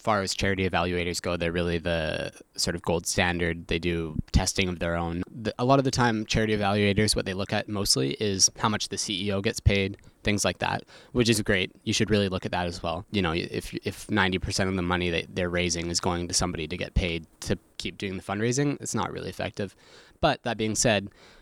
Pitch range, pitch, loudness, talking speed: 85-105 Hz, 95 Hz, -27 LUFS, 235 wpm